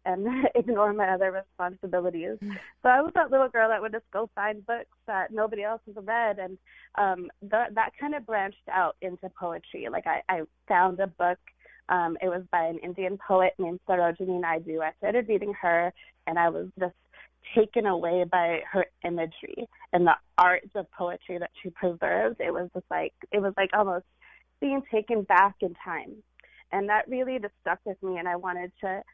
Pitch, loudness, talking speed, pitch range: 190 Hz, -28 LUFS, 190 wpm, 180-215 Hz